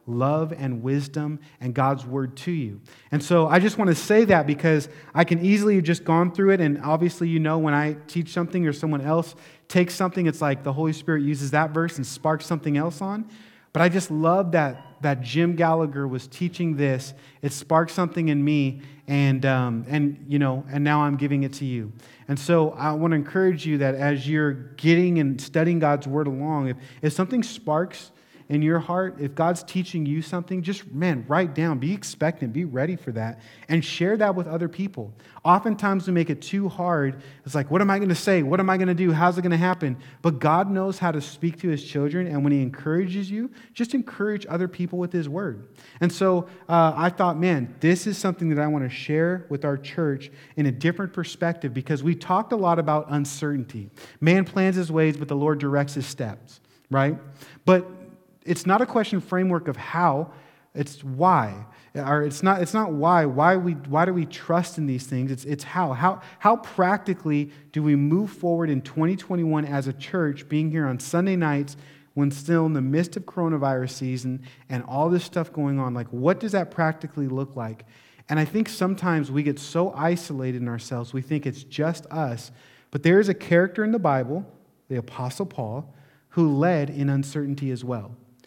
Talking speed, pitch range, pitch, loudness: 205 wpm, 140-175 Hz, 155 Hz, -24 LUFS